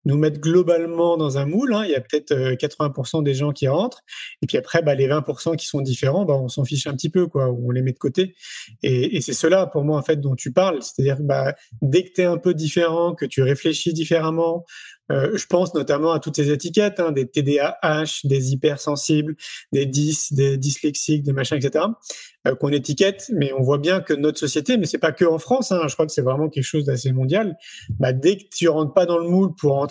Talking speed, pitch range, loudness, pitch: 250 wpm, 140-170 Hz, -21 LUFS, 155 Hz